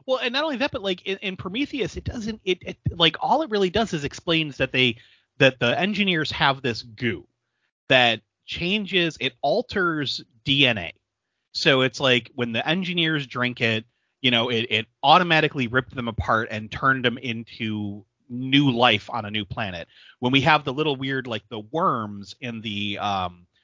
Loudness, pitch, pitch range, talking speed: -22 LUFS, 130 Hz, 115-160 Hz, 185 wpm